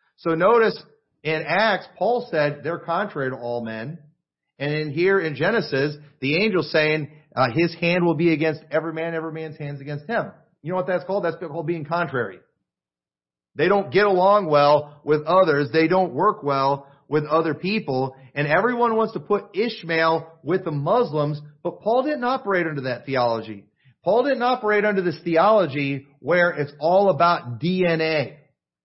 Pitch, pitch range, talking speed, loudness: 160 Hz, 145-185 Hz, 170 wpm, -22 LUFS